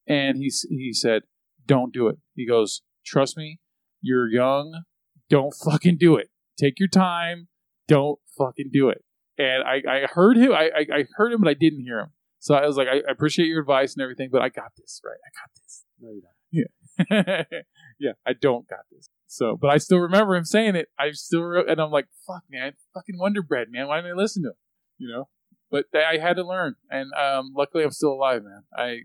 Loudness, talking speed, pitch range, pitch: -22 LUFS, 215 wpm, 135-175 Hz, 150 Hz